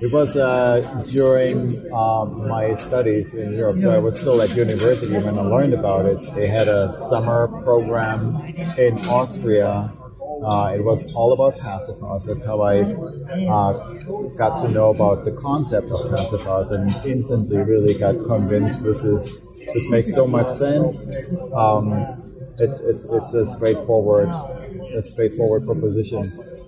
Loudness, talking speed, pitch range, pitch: -20 LUFS, 150 wpm, 105-130 Hz, 115 Hz